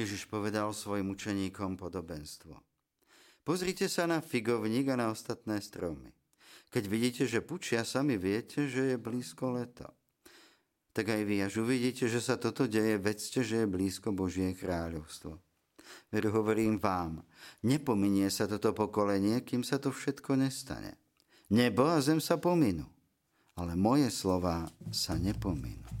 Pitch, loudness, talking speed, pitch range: 110 Hz, -33 LUFS, 140 wpm, 100-130 Hz